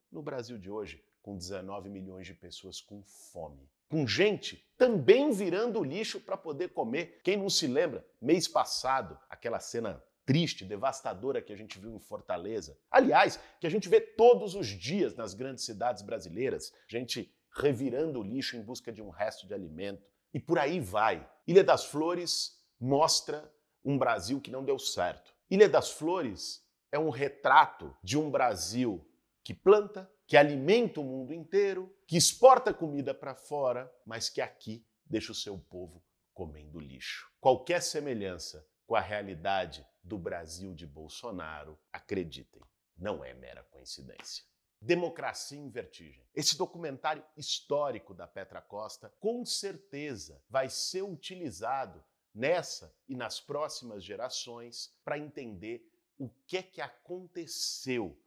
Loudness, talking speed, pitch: -31 LUFS, 145 wpm, 135 Hz